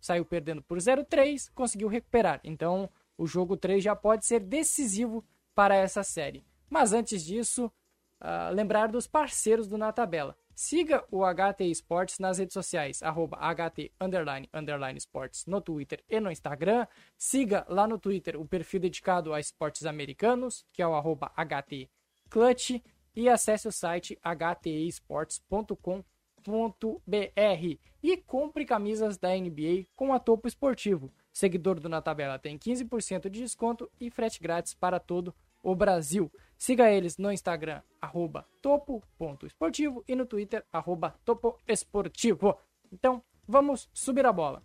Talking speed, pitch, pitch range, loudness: 140 wpm, 195 Hz, 170-235 Hz, -30 LUFS